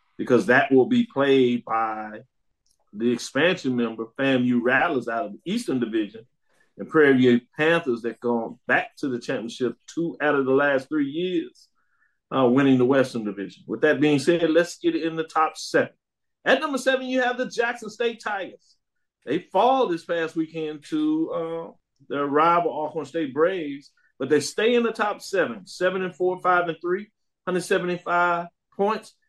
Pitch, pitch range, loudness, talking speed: 160 Hz, 130-195 Hz, -23 LUFS, 170 wpm